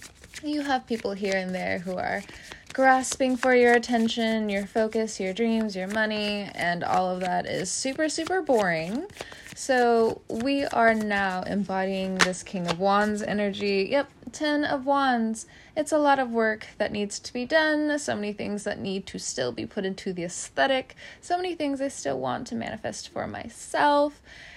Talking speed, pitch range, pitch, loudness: 175 wpm, 195-265 Hz, 220 Hz, -26 LUFS